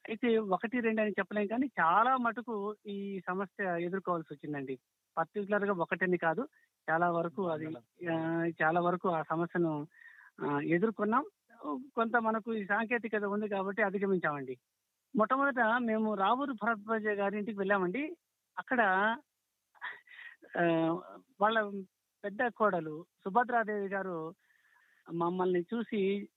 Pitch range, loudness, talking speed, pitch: 170-225 Hz, -33 LUFS, 100 wpm, 200 Hz